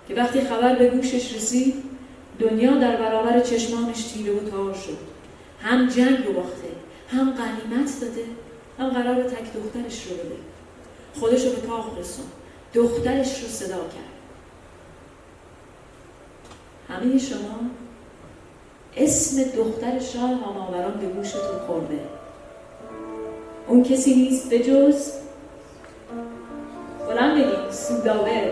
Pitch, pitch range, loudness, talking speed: 240 Hz, 220-260 Hz, -22 LUFS, 110 wpm